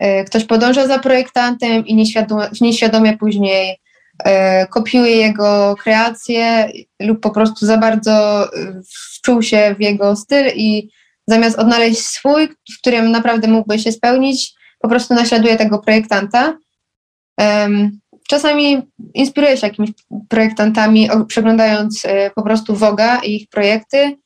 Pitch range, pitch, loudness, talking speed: 210-240 Hz, 220 Hz, -13 LUFS, 125 wpm